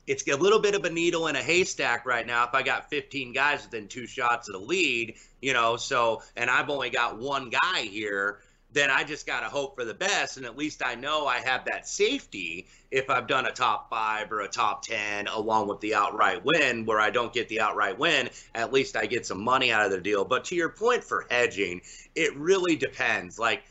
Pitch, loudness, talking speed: 135 Hz, -26 LUFS, 235 wpm